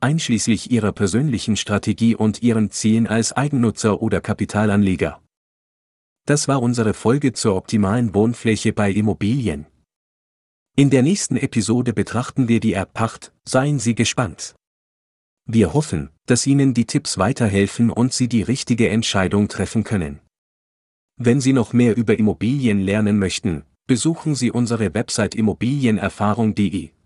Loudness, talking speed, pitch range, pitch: -19 LUFS, 130 wpm, 100-120 Hz, 110 Hz